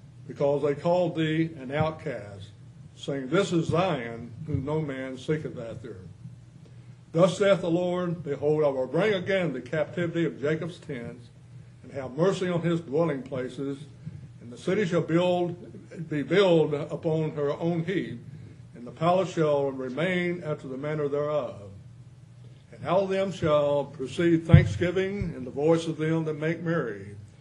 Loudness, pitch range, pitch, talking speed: -27 LUFS, 130-170 Hz, 150 Hz, 155 wpm